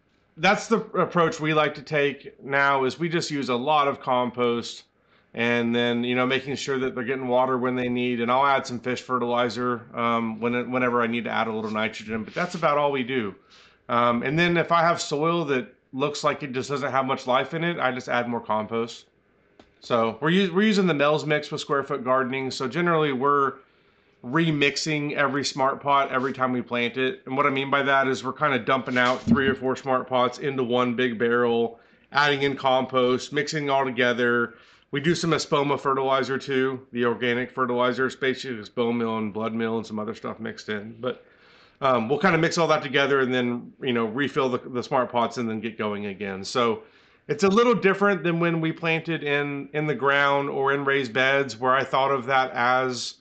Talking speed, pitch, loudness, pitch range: 220 wpm, 130 Hz, -24 LUFS, 120-145 Hz